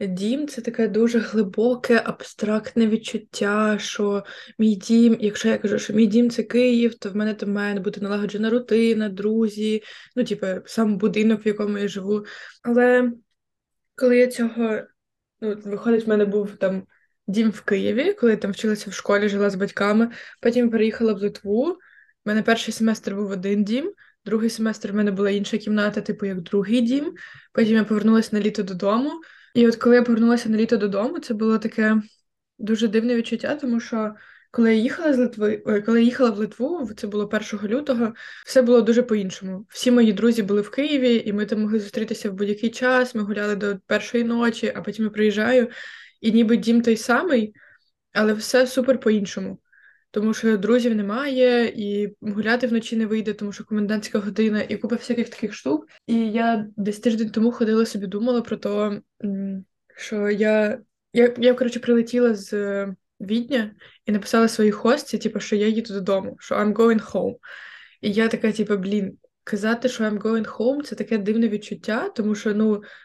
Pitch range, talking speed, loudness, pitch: 210-235 Hz, 175 wpm, -22 LUFS, 220 Hz